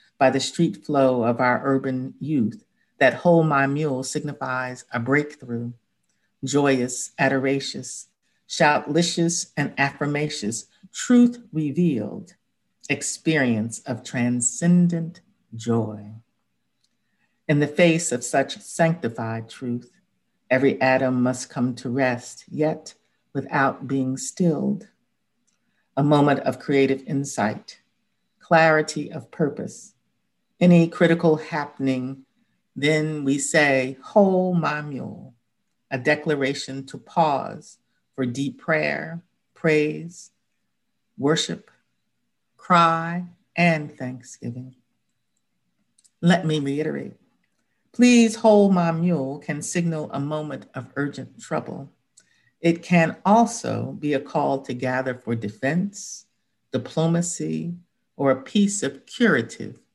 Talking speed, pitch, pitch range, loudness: 105 wpm, 145 Hz, 130-170 Hz, -22 LUFS